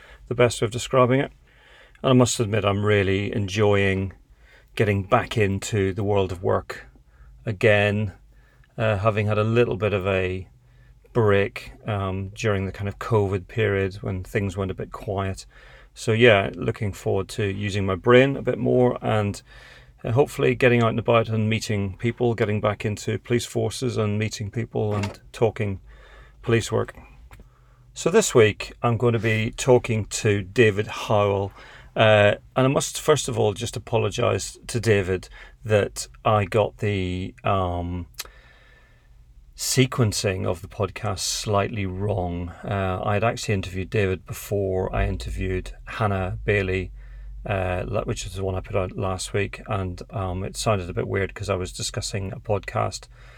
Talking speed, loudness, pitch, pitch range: 160 wpm, -23 LUFS, 105 Hz, 95-115 Hz